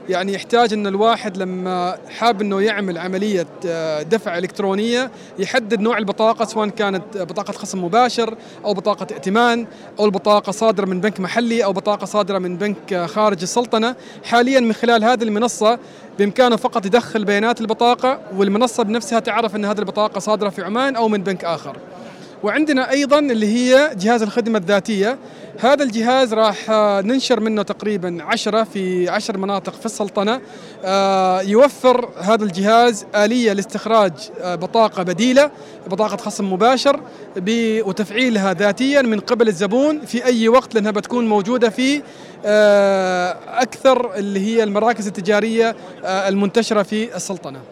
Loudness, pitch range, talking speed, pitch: -17 LUFS, 200-235 Hz, 135 wpm, 215 Hz